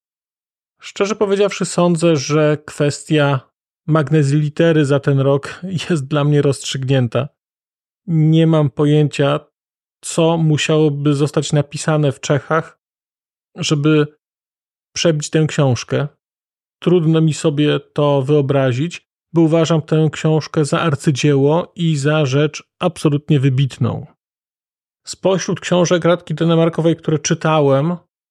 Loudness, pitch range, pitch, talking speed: -16 LUFS, 145-165 Hz, 155 Hz, 105 wpm